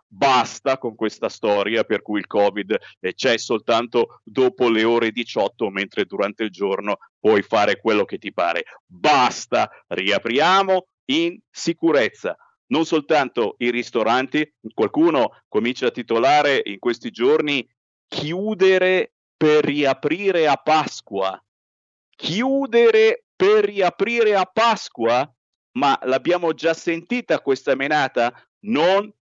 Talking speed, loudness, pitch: 115 wpm, -20 LUFS, 160 Hz